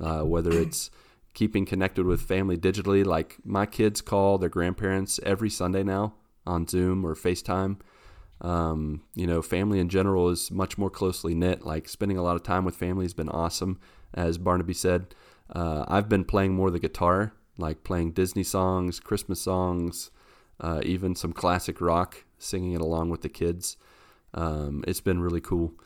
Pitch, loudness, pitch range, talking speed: 90 Hz, -27 LUFS, 85-95 Hz, 175 wpm